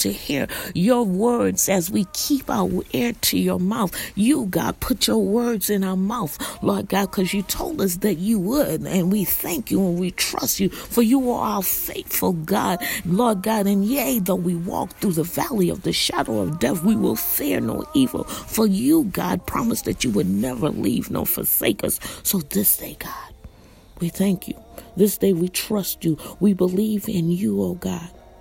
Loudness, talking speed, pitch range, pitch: -21 LUFS, 195 wpm, 185-225 Hz, 200 Hz